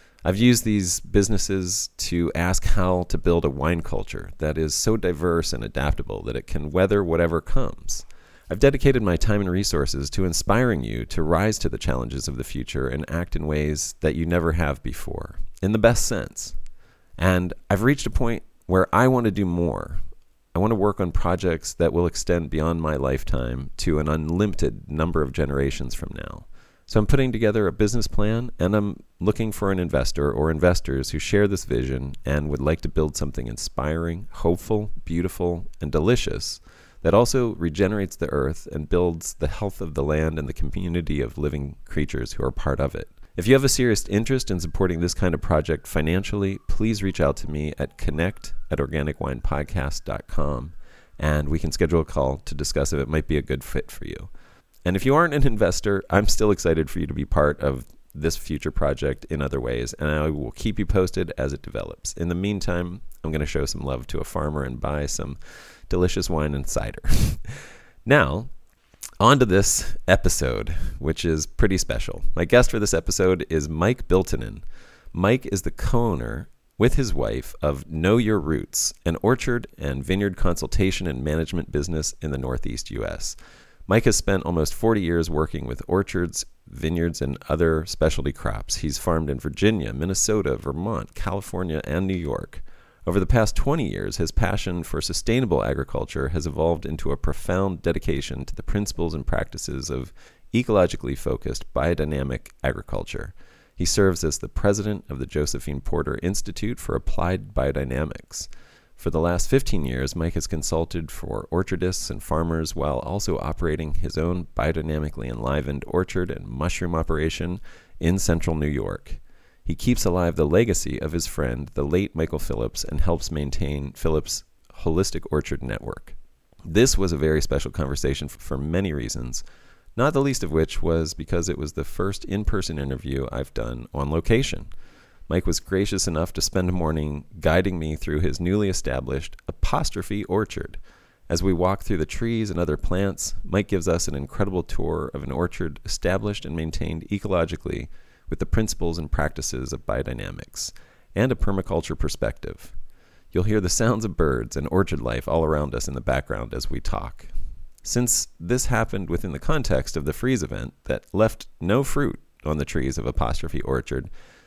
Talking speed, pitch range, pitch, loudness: 180 wpm, 75-95 Hz, 85 Hz, -24 LUFS